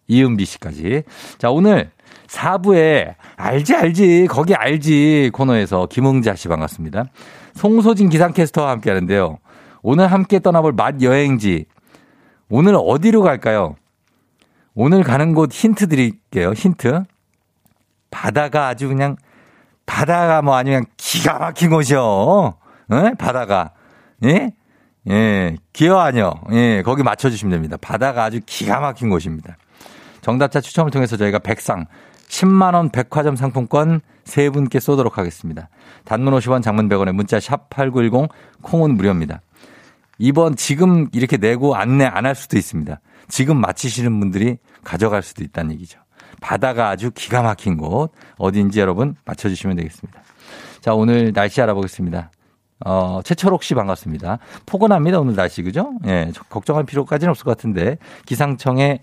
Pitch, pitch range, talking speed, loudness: 130 Hz, 100-150 Hz, 305 characters per minute, -16 LUFS